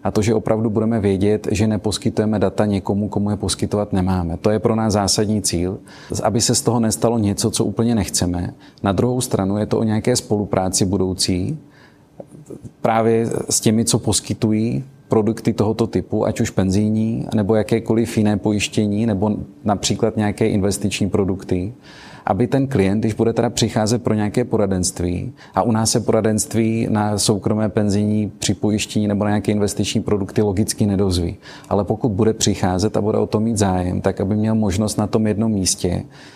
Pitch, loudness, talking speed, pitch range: 105 Hz, -19 LUFS, 170 wpm, 100-115 Hz